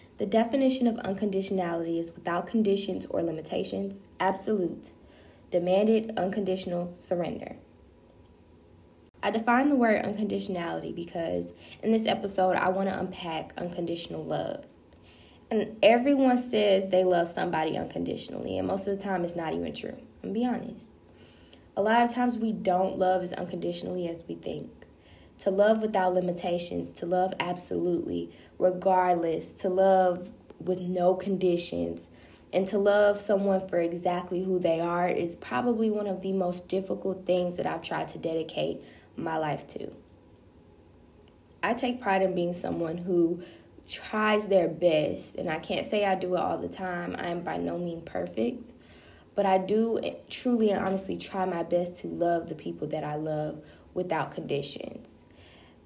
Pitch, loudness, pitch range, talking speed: 180 Hz, -28 LUFS, 165-200 Hz, 155 wpm